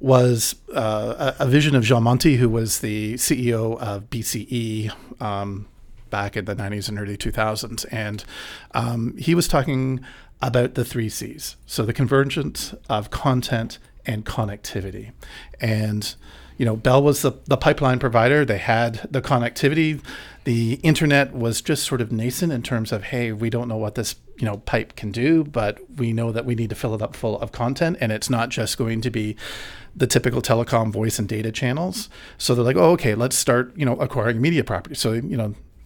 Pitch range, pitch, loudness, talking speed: 110-130 Hz, 120 Hz, -22 LUFS, 190 wpm